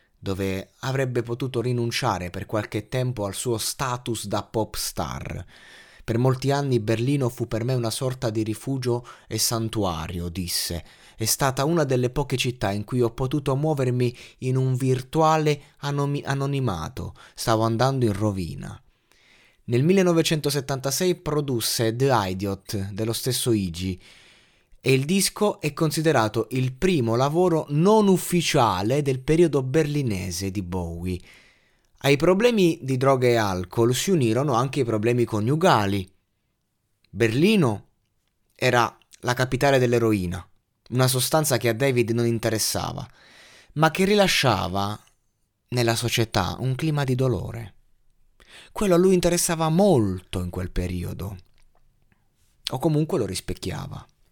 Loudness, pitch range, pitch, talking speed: -23 LUFS, 105-140 Hz, 120 Hz, 125 wpm